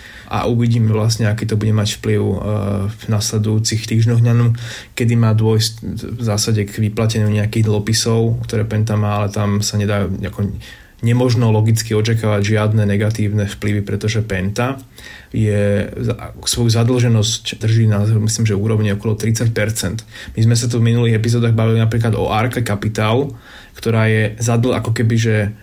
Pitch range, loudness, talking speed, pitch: 105-115 Hz, -17 LUFS, 150 wpm, 110 Hz